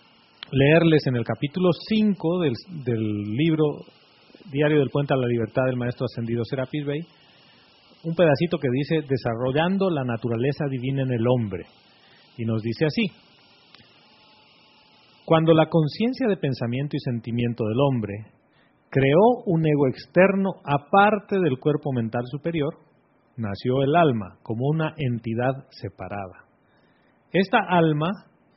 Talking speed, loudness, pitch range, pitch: 130 wpm, -23 LUFS, 120-165 Hz, 140 Hz